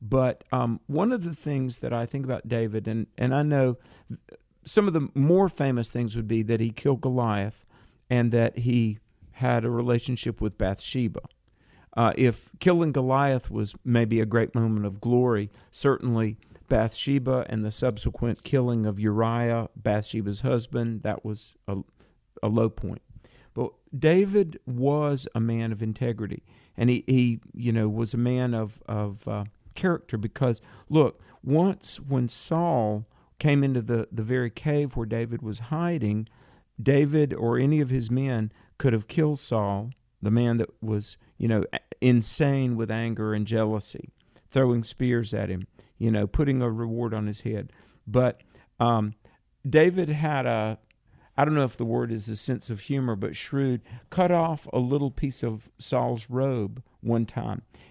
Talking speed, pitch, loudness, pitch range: 165 wpm, 120 Hz, -26 LUFS, 110-130 Hz